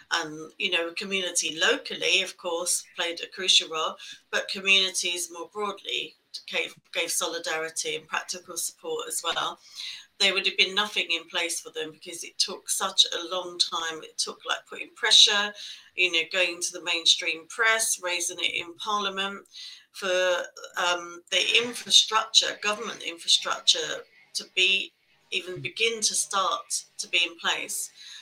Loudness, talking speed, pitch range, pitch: -25 LUFS, 150 wpm, 175-210 Hz, 185 Hz